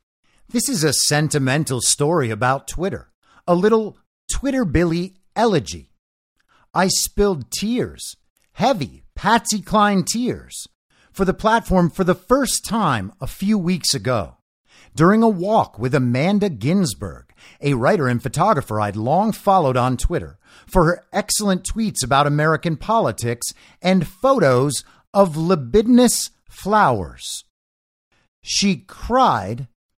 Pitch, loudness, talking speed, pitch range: 175 Hz, -19 LUFS, 120 wpm, 125-205 Hz